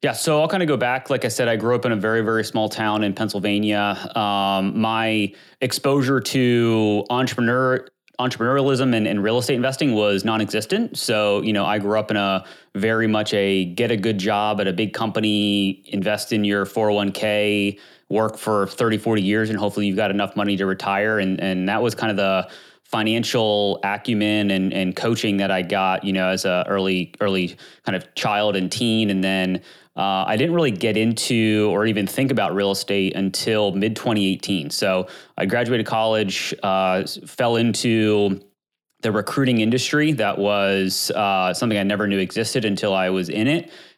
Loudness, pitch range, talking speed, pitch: -21 LUFS, 100-115 Hz, 185 wpm, 105 Hz